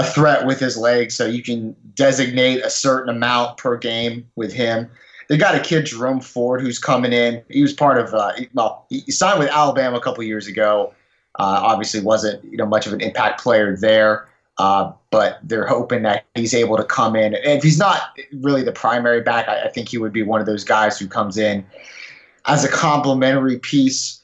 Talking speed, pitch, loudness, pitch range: 215 wpm, 120 Hz, -18 LUFS, 110-135 Hz